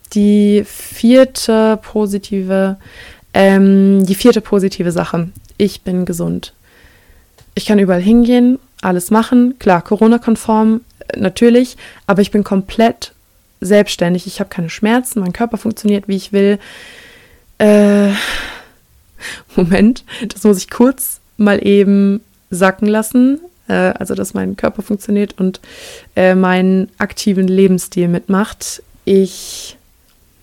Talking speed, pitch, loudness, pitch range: 115 wpm, 205 Hz, -13 LUFS, 190-220 Hz